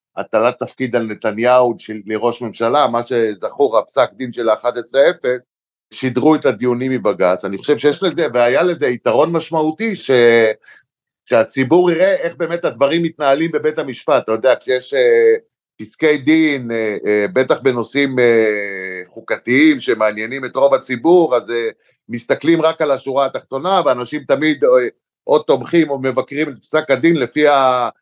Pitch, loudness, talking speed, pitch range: 135 Hz, -16 LUFS, 155 wpm, 120-160 Hz